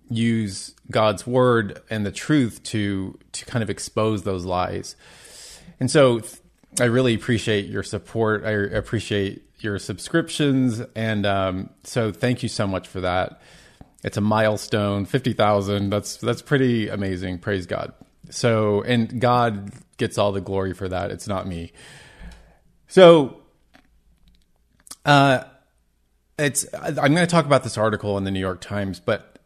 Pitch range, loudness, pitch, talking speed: 100-120 Hz, -22 LUFS, 105 Hz, 145 wpm